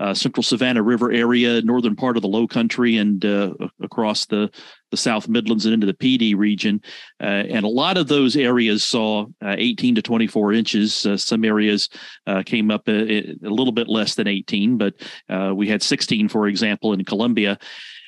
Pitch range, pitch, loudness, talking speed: 105-120 Hz, 110 Hz, -19 LUFS, 195 wpm